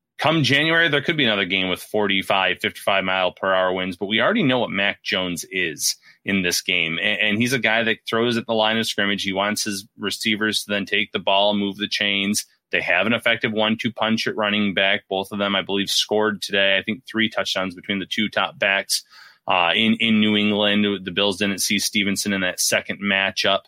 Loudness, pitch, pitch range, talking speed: -20 LUFS, 100 Hz, 95-110 Hz, 225 wpm